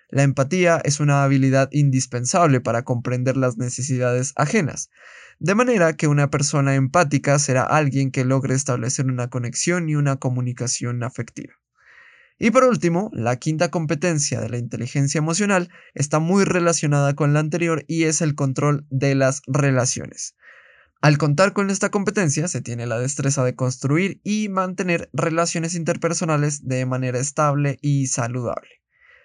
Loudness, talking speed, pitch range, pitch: -20 LUFS, 145 wpm, 130-165 Hz, 145 Hz